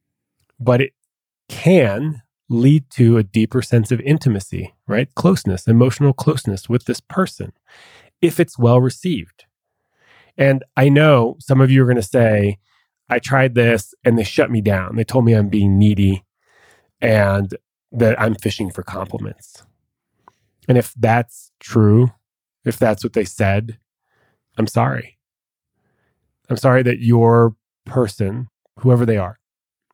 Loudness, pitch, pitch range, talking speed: -16 LUFS, 120 Hz, 110-130 Hz, 140 wpm